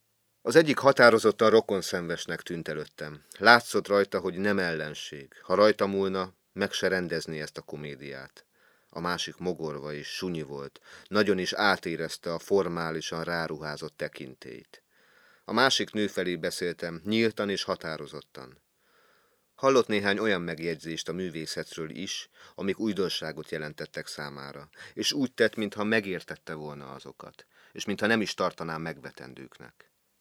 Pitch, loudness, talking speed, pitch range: 85 Hz, -28 LUFS, 130 wpm, 75-100 Hz